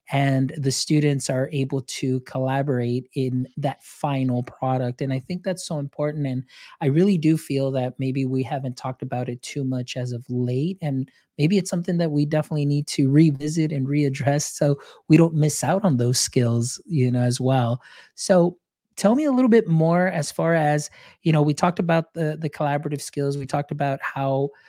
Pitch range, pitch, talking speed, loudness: 130-155 Hz, 140 Hz, 195 wpm, -23 LUFS